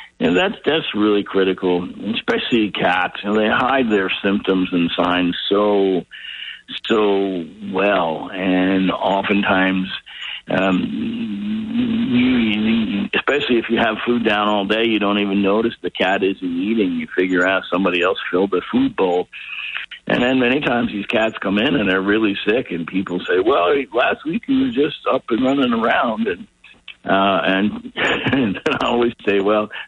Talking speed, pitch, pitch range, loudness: 160 wpm, 105 Hz, 95-120 Hz, -18 LUFS